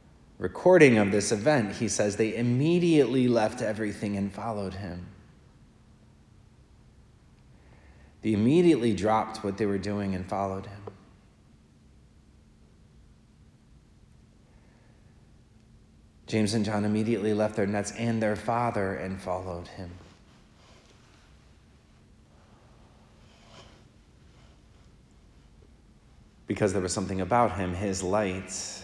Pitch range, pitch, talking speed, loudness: 95-110 Hz, 105 Hz, 90 wpm, -27 LUFS